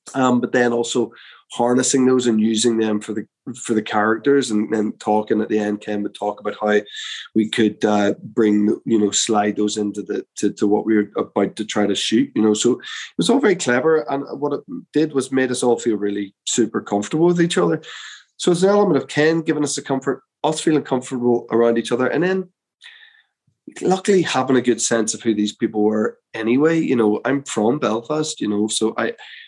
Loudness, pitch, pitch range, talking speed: -19 LUFS, 120 Hz, 105-145 Hz, 215 wpm